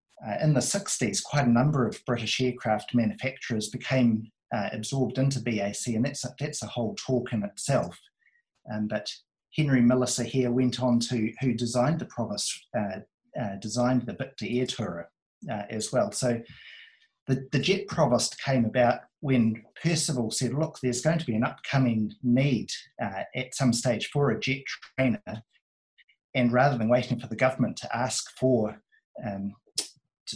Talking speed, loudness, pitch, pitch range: 165 wpm, -28 LUFS, 125 Hz, 115-135 Hz